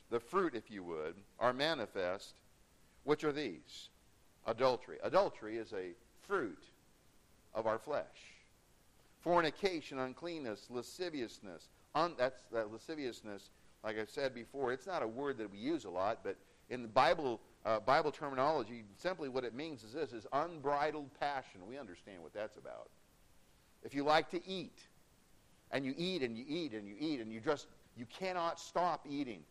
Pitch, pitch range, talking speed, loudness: 140 Hz, 115-170 Hz, 165 wpm, -39 LUFS